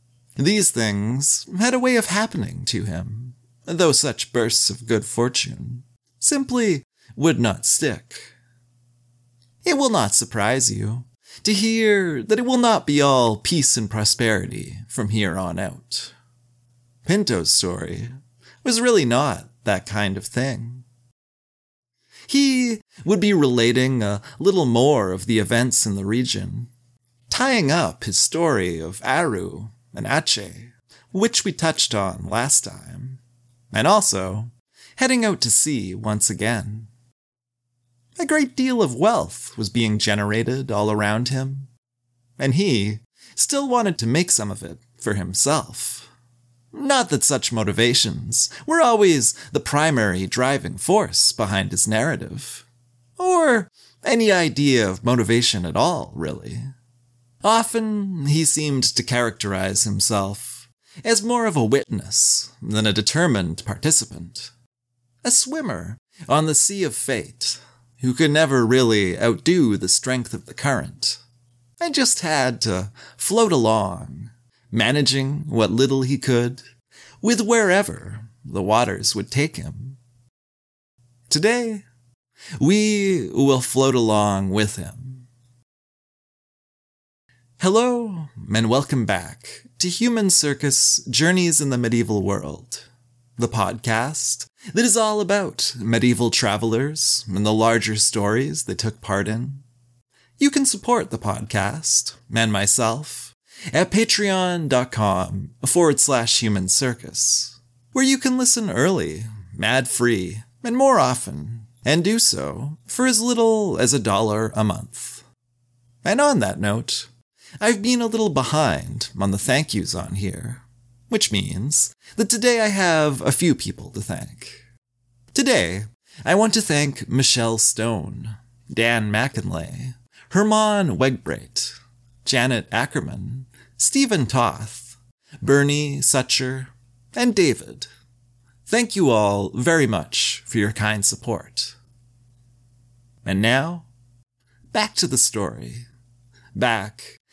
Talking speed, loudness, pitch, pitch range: 125 wpm, -20 LUFS, 120 Hz, 115-150 Hz